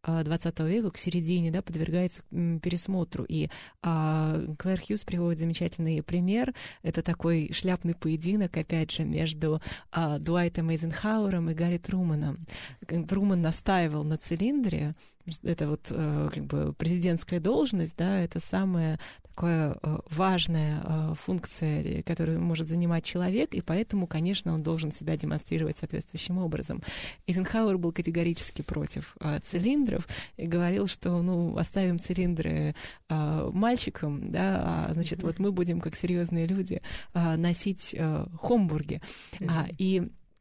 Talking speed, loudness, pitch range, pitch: 120 wpm, -30 LUFS, 160-180 Hz, 170 Hz